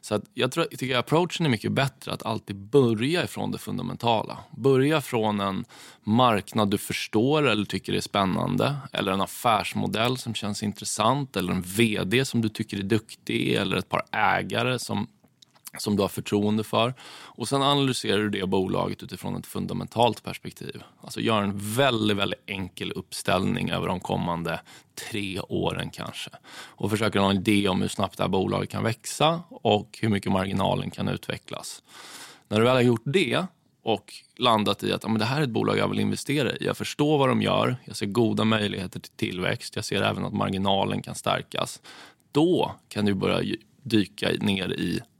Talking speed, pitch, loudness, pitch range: 185 wpm, 110 Hz, -26 LUFS, 100-130 Hz